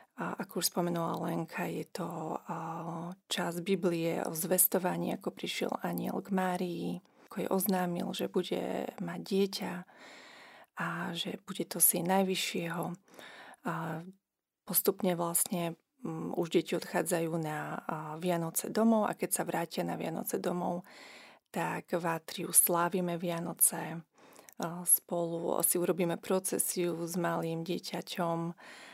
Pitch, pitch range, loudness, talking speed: 175 Hz, 170-185 Hz, -33 LUFS, 115 wpm